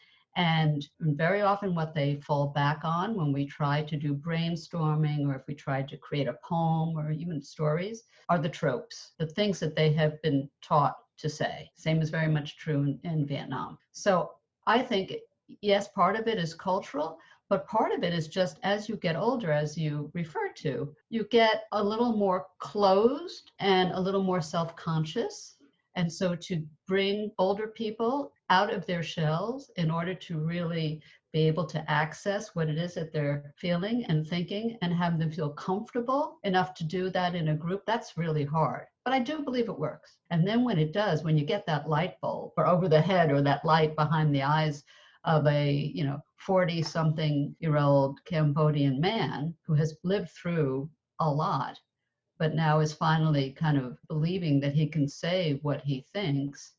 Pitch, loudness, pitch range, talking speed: 160 Hz, -29 LUFS, 150-190 Hz, 190 wpm